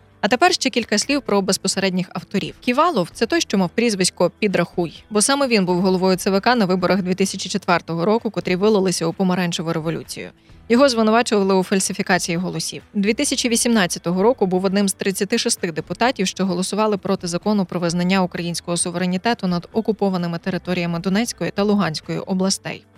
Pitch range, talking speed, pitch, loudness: 180-215 Hz, 150 wpm, 195 Hz, -19 LUFS